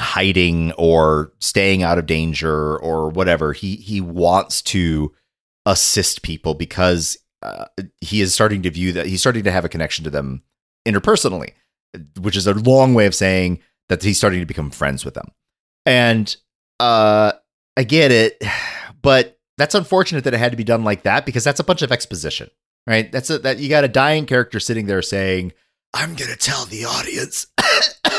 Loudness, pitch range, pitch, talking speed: -17 LUFS, 85-120 Hz, 95 Hz, 180 wpm